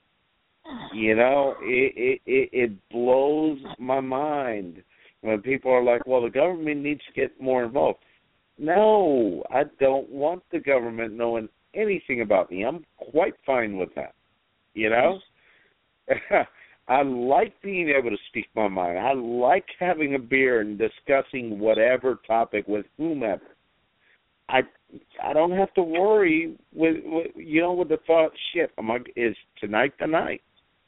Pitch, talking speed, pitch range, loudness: 135 Hz, 145 wpm, 120-170 Hz, -24 LUFS